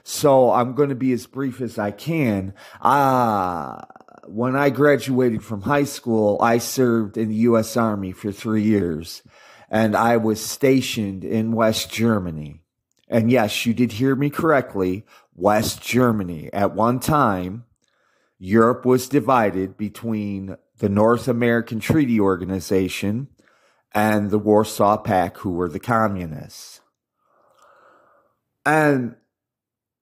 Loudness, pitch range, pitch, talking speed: -20 LUFS, 105-125 Hz, 110 Hz, 130 wpm